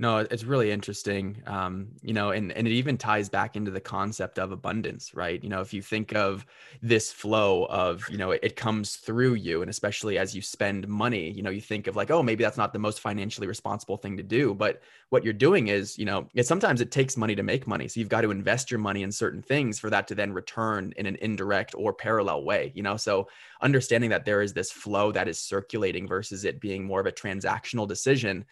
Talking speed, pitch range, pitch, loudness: 240 wpm, 100-115 Hz, 105 Hz, -28 LUFS